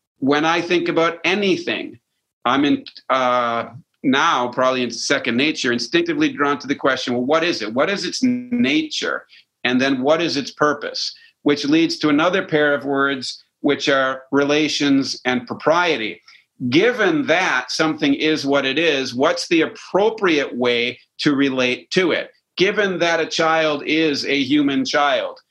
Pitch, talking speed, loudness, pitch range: 145 Hz, 160 wpm, -19 LUFS, 130-170 Hz